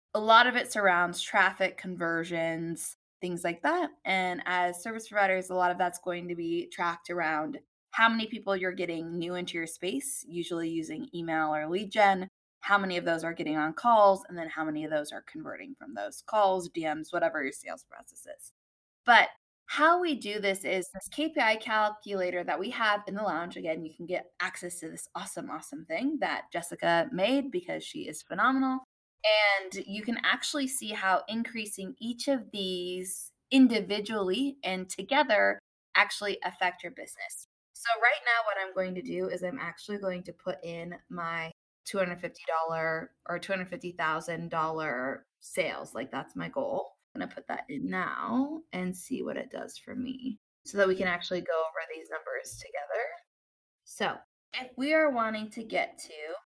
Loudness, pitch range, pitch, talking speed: -30 LUFS, 170-230 Hz, 185 Hz, 180 wpm